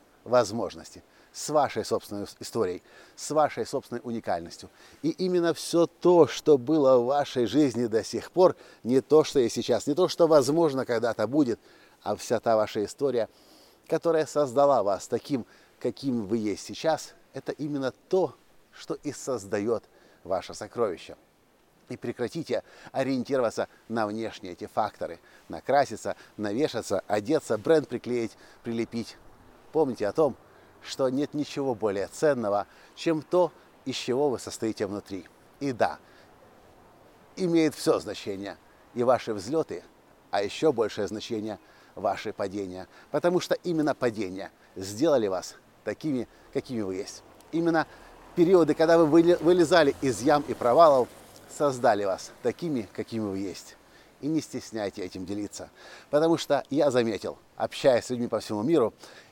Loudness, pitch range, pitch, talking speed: -27 LUFS, 110-160 Hz, 130 Hz, 135 wpm